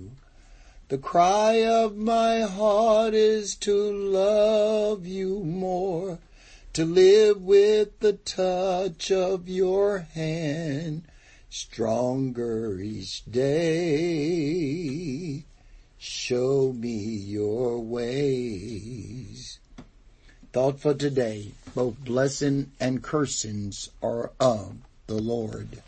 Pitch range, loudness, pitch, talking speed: 120-190 Hz, -25 LUFS, 140 Hz, 85 wpm